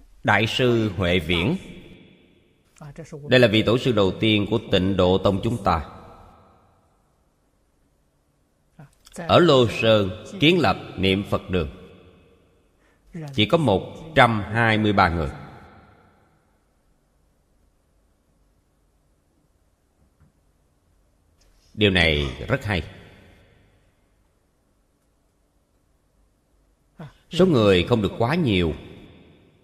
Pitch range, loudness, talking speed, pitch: 75-105 Hz, -20 LUFS, 80 wpm, 95 Hz